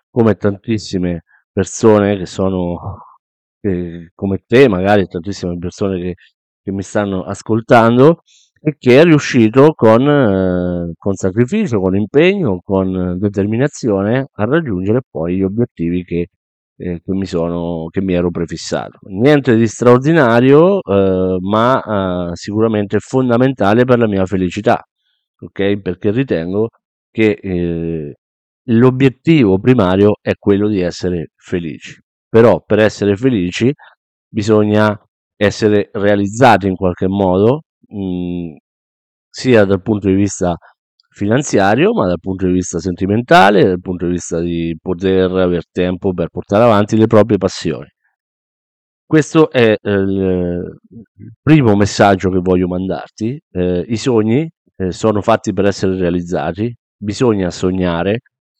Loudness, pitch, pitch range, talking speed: -14 LUFS, 100 Hz, 90-115 Hz, 125 wpm